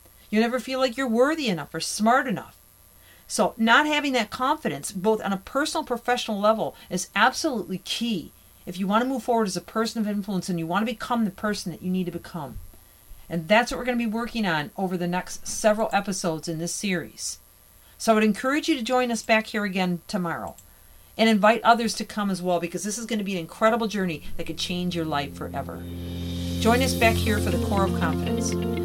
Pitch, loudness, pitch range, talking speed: 195 Hz, -25 LUFS, 155-230 Hz, 225 wpm